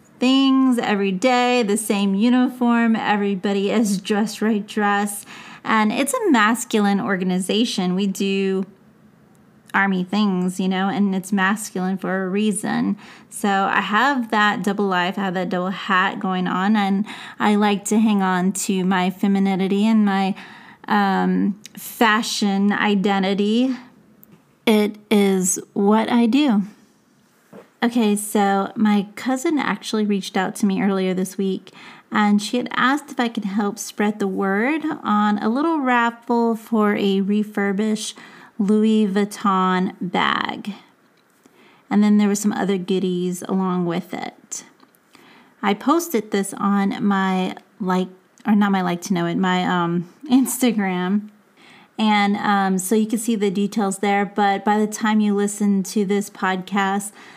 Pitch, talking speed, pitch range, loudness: 205 Hz, 145 wpm, 195-220 Hz, -20 LUFS